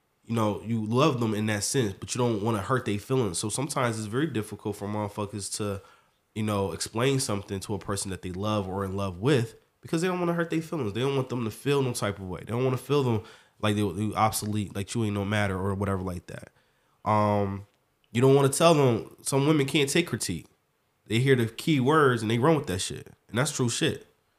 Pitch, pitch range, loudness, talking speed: 110 Hz, 100-130 Hz, -27 LUFS, 250 wpm